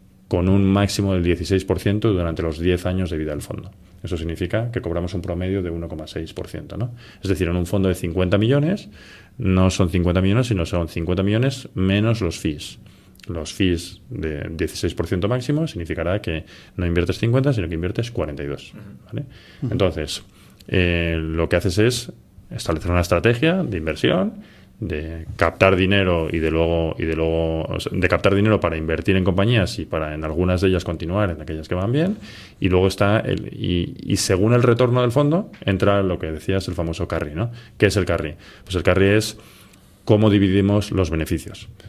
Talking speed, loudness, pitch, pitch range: 185 wpm, -21 LUFS, 95 Hz, 85-105 Hz